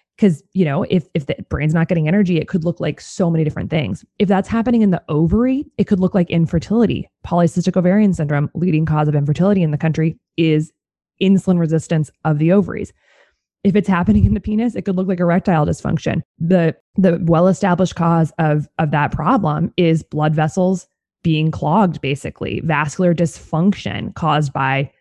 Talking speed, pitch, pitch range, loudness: 180 wpm, 170 Hz, 155-190 Hz, -17 LUFS